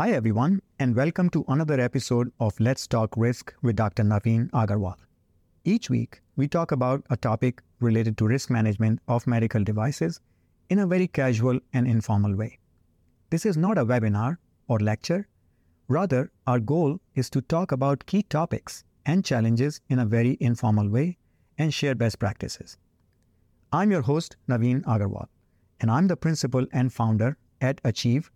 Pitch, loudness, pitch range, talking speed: 125 Hz, -25 LUFS, 110-140 Hz, 160 wpm